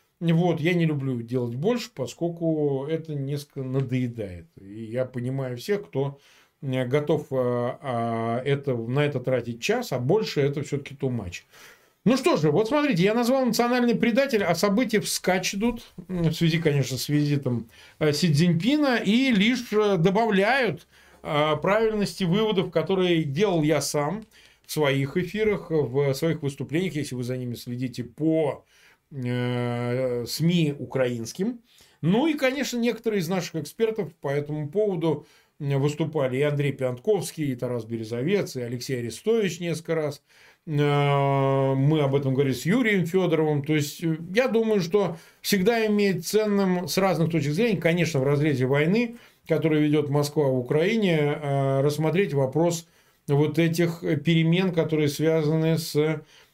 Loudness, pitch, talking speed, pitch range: -25 LUFS, 155 Hz, 135 wpm, 135-190 Hz